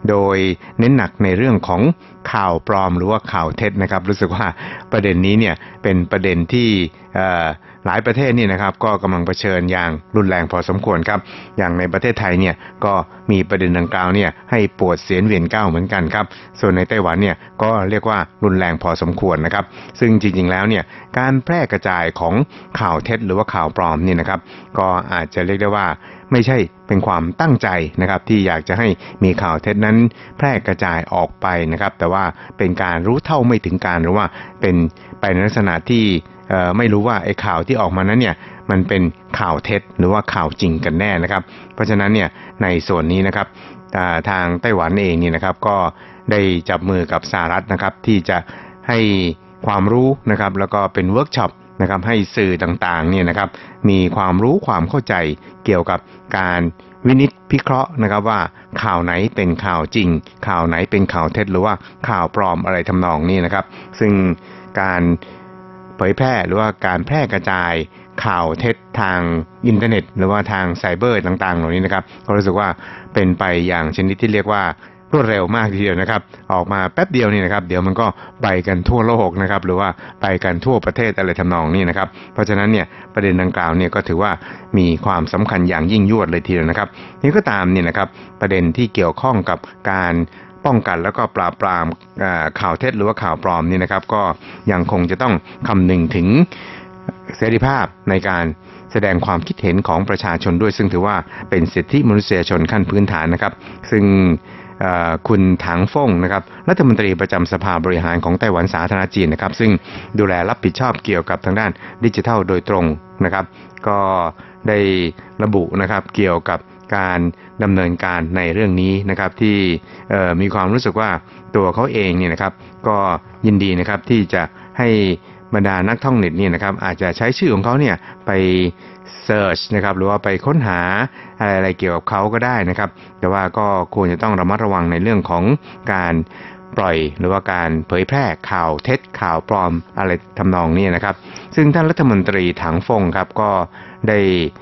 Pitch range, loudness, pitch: 90-105 Hz, -17 LUFS, 95 Hz